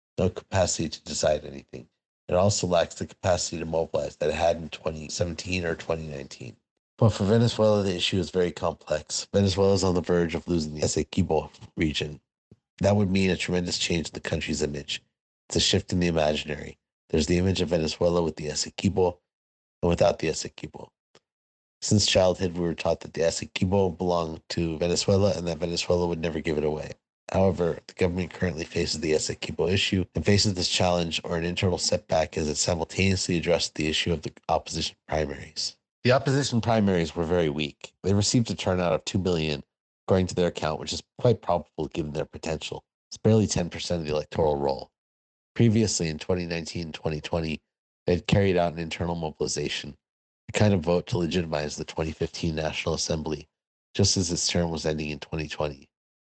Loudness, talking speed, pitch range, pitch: -26 LUFS, 185 wpm, 75-95 Hz, 85 Hz